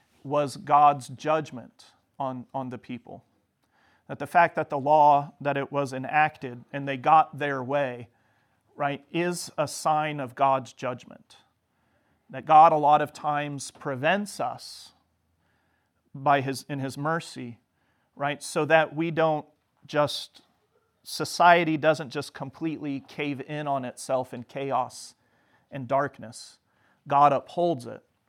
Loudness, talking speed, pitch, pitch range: -25 LUFS, 135 wpm, 140 Hz, 130-150 Hz